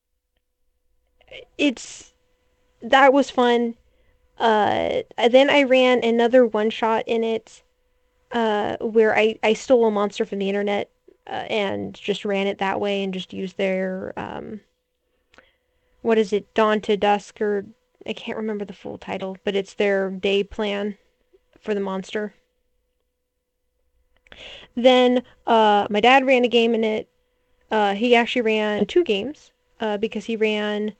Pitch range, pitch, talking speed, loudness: 205-250 Hz, 220 Hz, 145 wpm, -21 LUFS